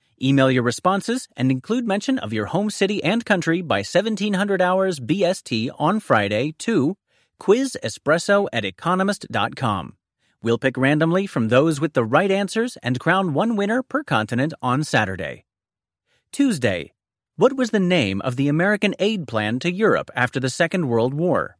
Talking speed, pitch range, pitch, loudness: 155 wpm, 130-200 Hz, 170 Hz, -21 LUFS